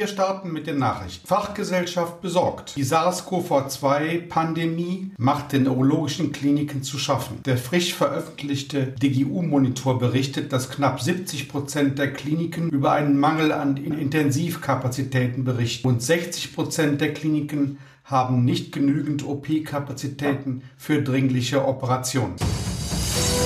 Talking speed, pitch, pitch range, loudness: 105 wpm, 140 Hz, 135-155 Hz, -23 LUFS